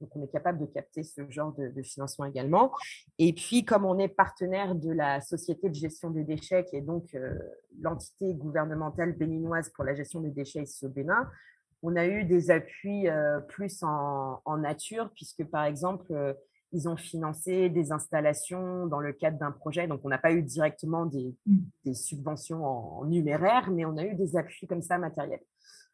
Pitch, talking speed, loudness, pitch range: 160 Hz, 195 wpm, -30 LUFS, 145-180 Hz